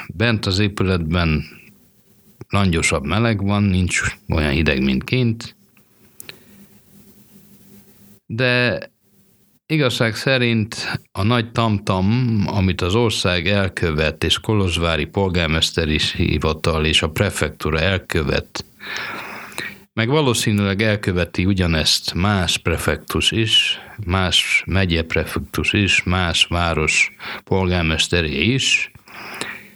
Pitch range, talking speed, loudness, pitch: 80-110 Hz, 90 wpm, -18 LUFS, 95 Hz